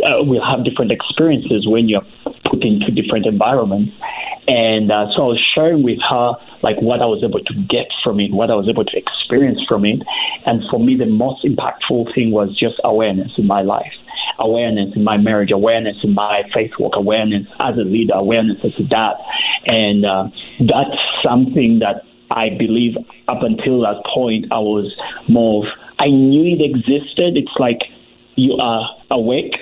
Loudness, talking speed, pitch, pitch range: -15 LUFS, 180 wpm, 110 Hz, 105-120 Hz